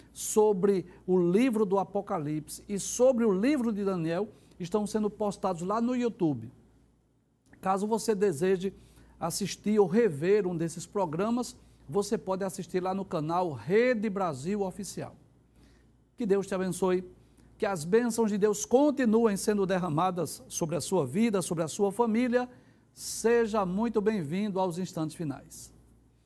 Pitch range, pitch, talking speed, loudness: 175-215 Hz, 195 Hz, 140 wpm, -29 LUFS